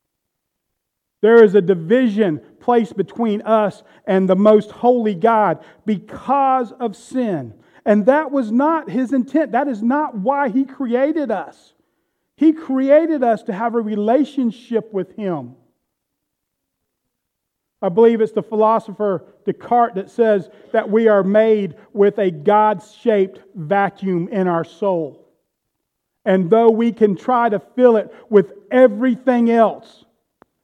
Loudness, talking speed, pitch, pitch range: -17 LUFS, 135 wpm, 220 Hz, 200-245 Hz